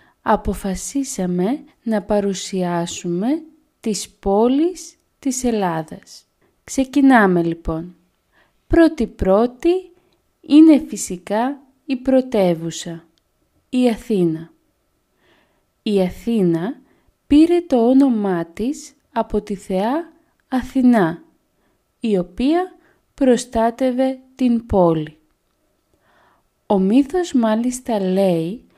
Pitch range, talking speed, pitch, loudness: 190-275 Hz, 75 wpm, 235 Hz, -18 LUFS